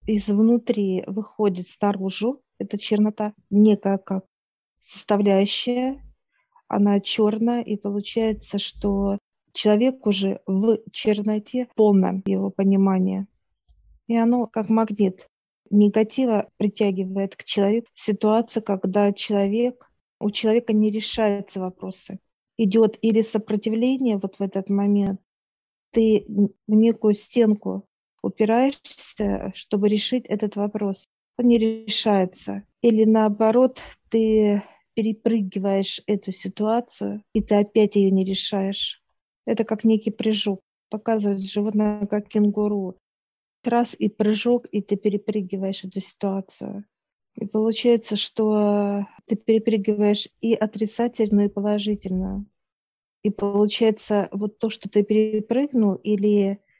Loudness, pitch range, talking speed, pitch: -22 LUFS, 200-220 Hz, 105 wpm, 210 Hz